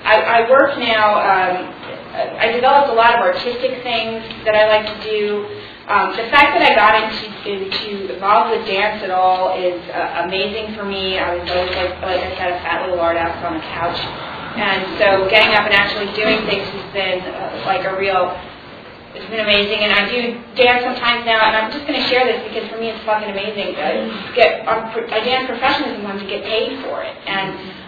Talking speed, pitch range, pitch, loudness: 210 wpm, 190-225 Hz, 210 Hz, -16 LUFS